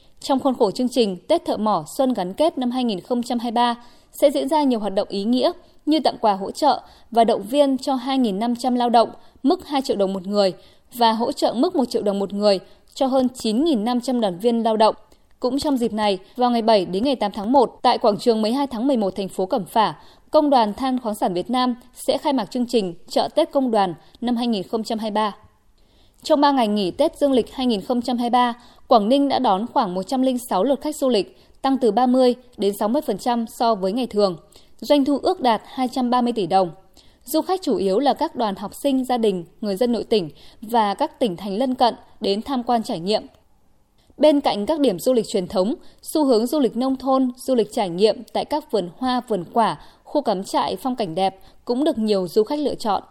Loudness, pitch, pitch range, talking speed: -21 LUFS, 240 Hz, 210-270 Hz, 215 wpm